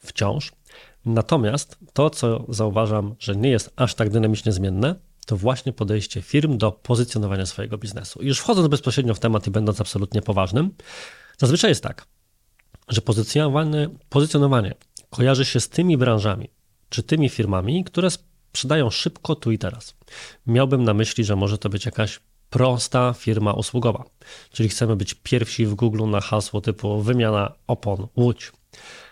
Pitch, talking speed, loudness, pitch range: 115 Hz, 145 wpm, -22 LUFS, 105-135 Hz